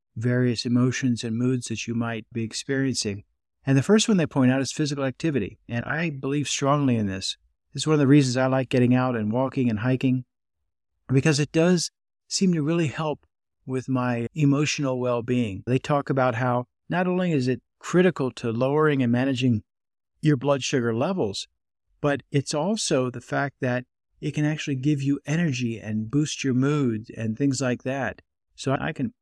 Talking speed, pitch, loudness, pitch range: 185 wpm, 130 Hz, -24 LUFS, 120-145 Hz